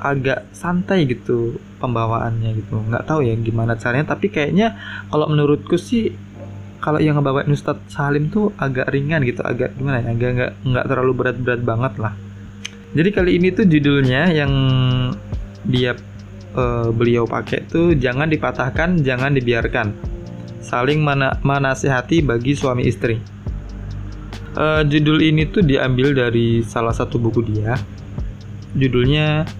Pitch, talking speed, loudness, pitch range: 125 Hz, 130 wpm, -18 LUFS, 115-145 Hz